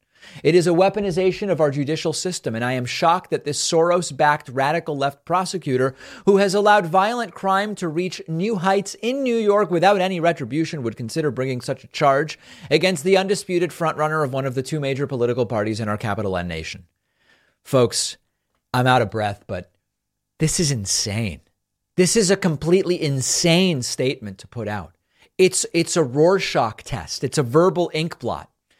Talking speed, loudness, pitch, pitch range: 175 wpm, -20 LUFS, 155 Hz, 125-185 Hz